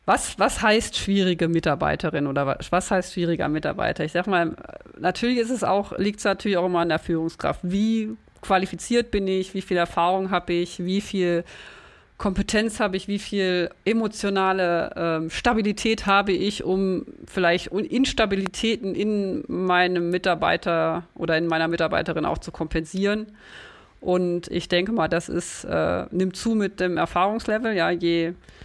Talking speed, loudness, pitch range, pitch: 155 wpm, -24 LUFS, 170-205 Hz, 185 Hz